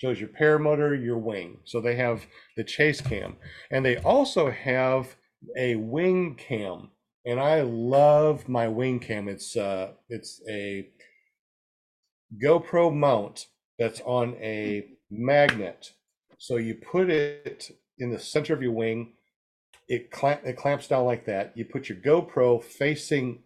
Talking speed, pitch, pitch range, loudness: 145 wpm, 125 Hz, 115-145 Hz, -26 LUFS